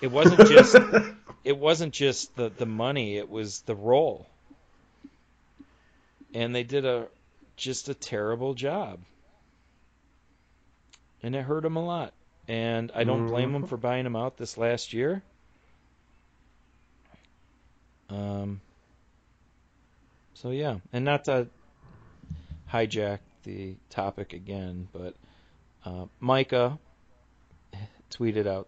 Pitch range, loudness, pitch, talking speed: 95-130 Hz, -25 LUFS, 115 Hz, 115 wpm